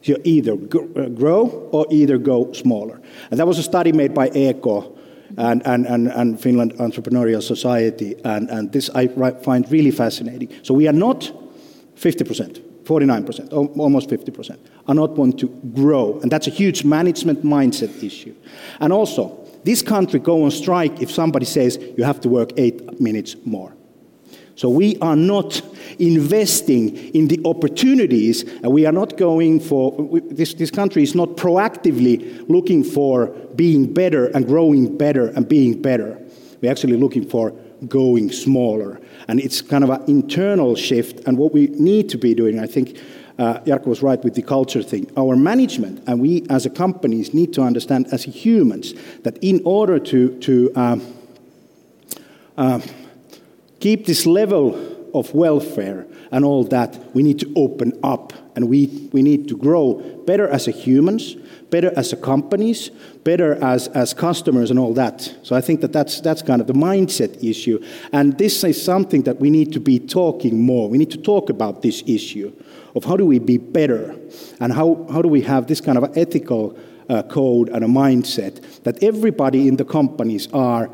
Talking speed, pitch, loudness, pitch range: 175 wpm, 140 Hz, -17 LUFS, 125-165 Hz